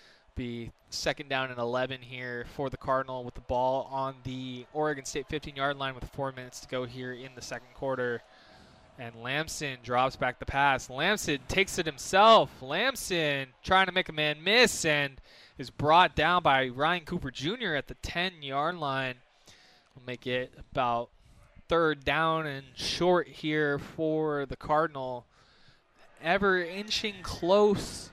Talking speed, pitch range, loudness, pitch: 160 wpm, 125-160 Hz, -29 LUFS, 135 Hz